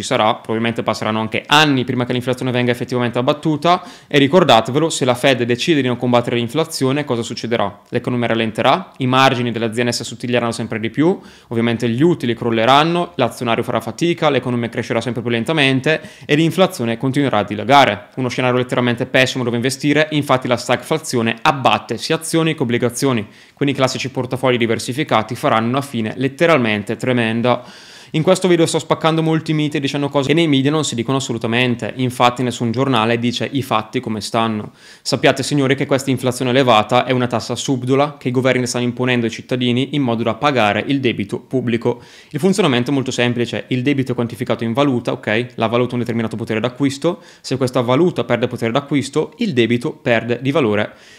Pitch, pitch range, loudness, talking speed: 125 Hz, 120-140 Hz, -17 LUFS, 180 wpm